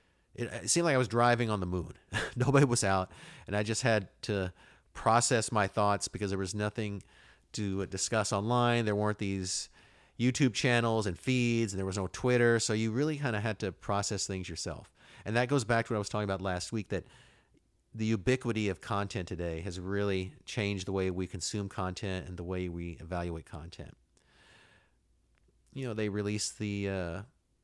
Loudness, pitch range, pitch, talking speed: -32 LUFS, 95-115 Hz, 105 Hz, 190 wpm